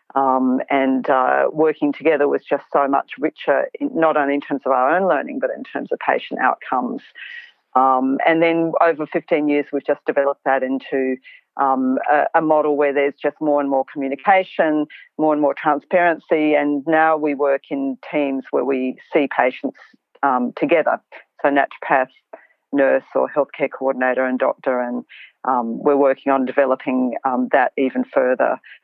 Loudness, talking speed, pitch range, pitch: -19 LUFS, 170 wpm, 130-155 Hz, 140 Hz